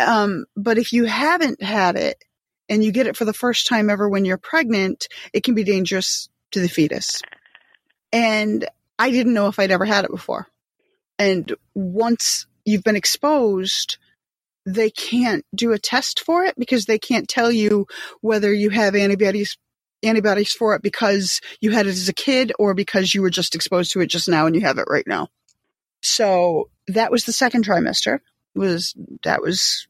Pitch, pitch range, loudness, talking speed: 215 Hz, 195-235 Hz, -19 LUFS, 185 wpm